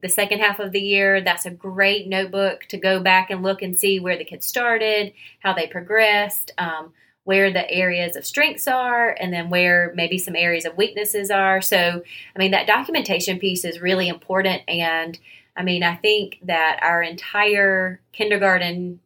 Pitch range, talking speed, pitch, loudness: 175-200 Hz, 185 wpm, 190 Hz, -19 LUFS